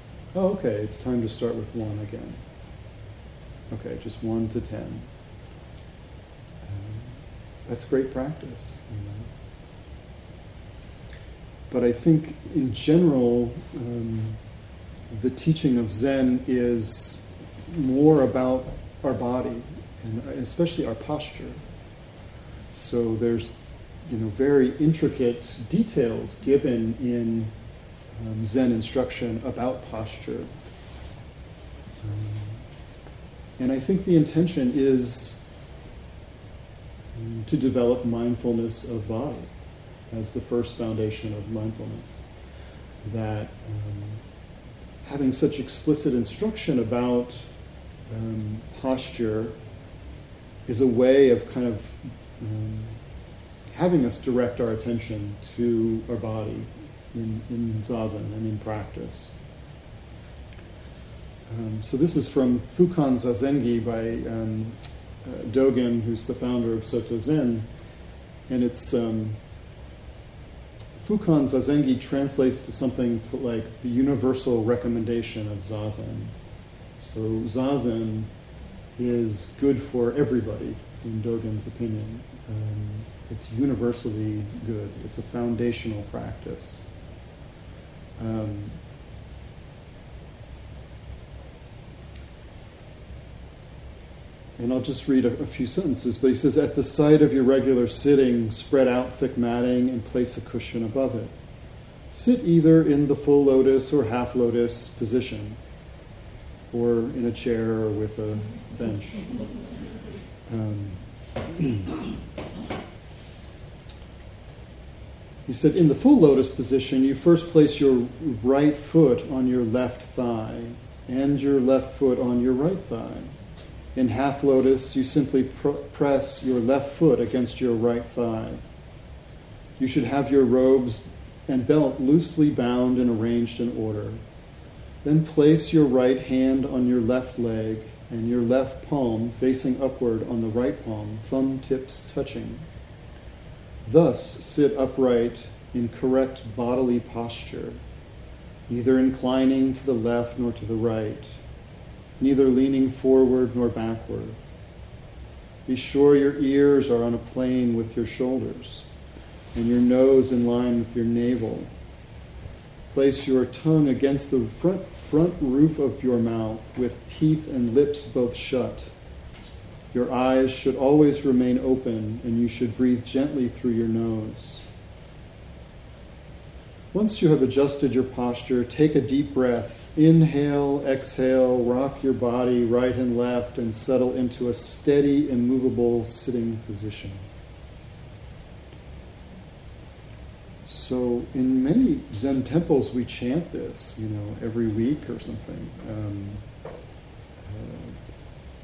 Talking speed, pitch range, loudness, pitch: 115 wpm, 110-130 Hz, -24 LUFS, 120 Hz